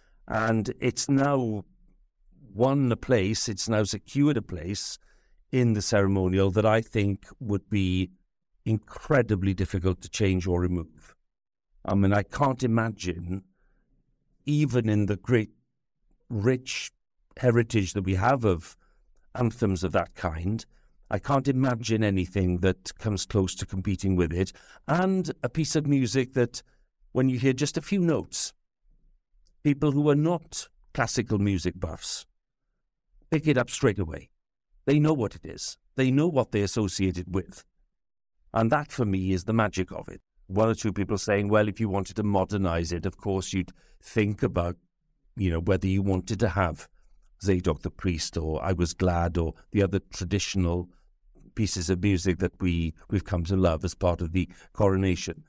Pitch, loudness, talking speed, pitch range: 100 Hz, -27 LUFS, 160 wpm, 95-120 Hz